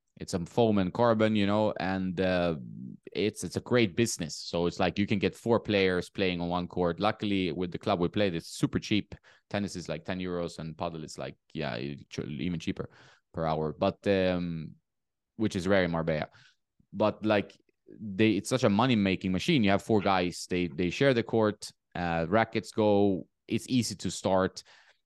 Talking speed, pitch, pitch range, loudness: 190 wpm, 95 Hz, 85-105 Hz, -29 LUFS